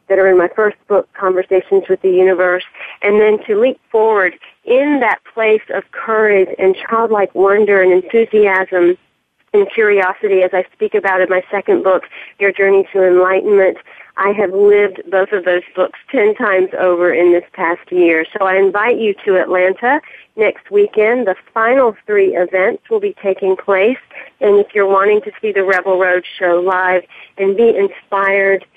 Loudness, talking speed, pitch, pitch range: -13 LUFS, 175 wpm, 195 Hz, 185-215 Hz